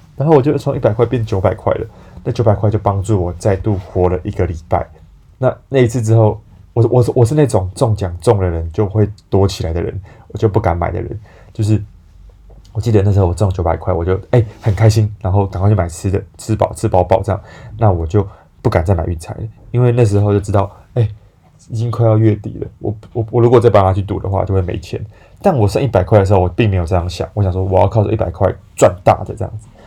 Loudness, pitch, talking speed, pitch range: -15 LUFS, 105 Hz, 340 characters per minute, 95-110 Hz